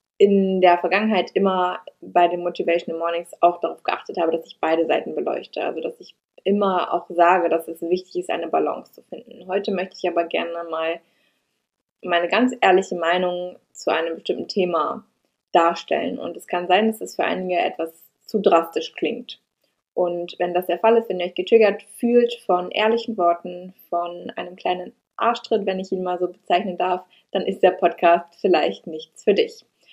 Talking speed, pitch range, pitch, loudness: 185 wpm, 170-195 Hz, 180 Hz, -21 LUFS